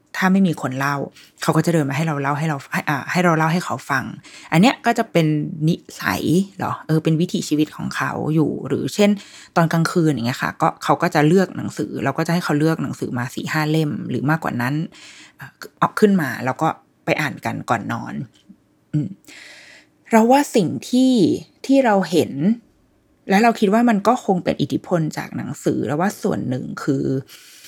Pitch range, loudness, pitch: 150-205 Hz, -20 LUFS, 170 Hz